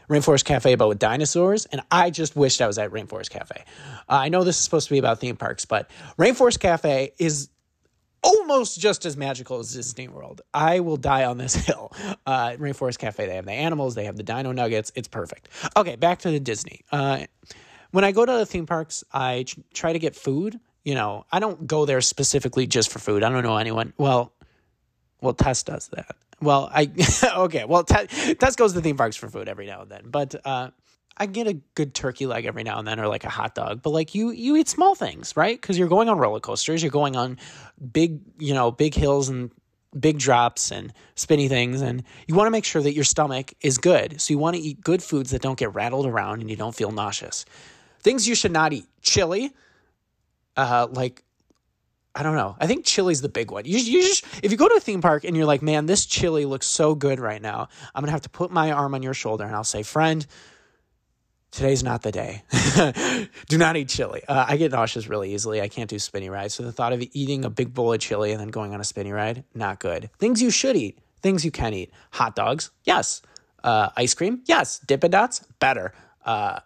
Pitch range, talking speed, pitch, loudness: 120-165 Hz, 225 wpm, 140 Hz, -22 LUFS